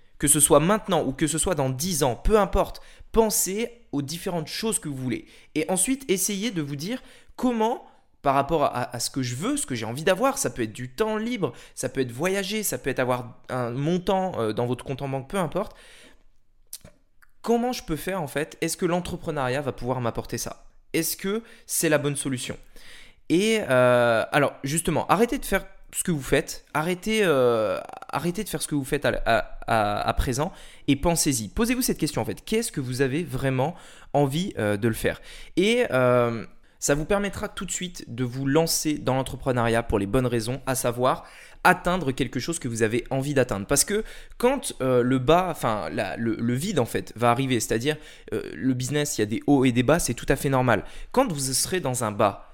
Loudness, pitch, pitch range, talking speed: -25 LUFS, 145 Hz, 125-185 Hz, 215 wpm